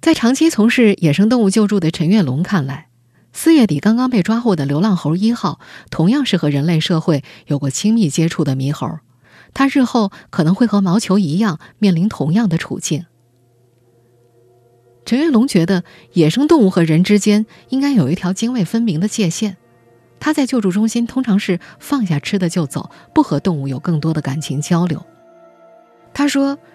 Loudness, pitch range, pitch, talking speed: -16 LUFS, 150-225 Hz, 185 Hz, 270 characters per minute